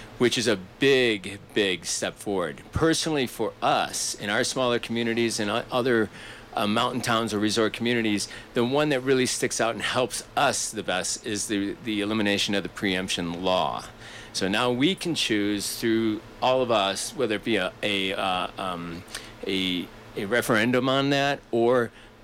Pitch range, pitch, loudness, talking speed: 100-125 Hz, 110 Hz, -25 LUFS, 170 wpm